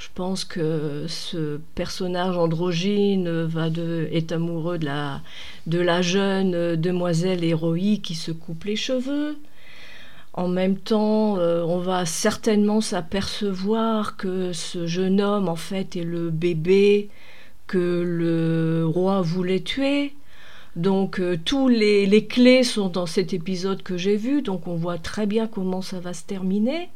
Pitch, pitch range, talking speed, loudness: 185 Hz, 170-205 Hz, 145 wpm, -23 LUFS